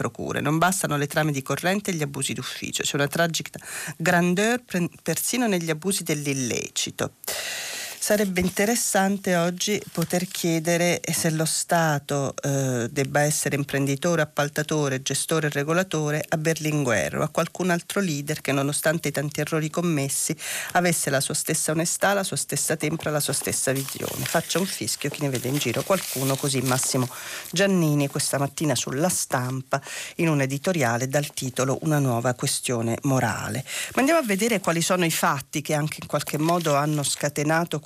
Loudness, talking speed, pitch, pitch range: -24 LUFS, 160 wpm, 155 Hz, 140-170 Hz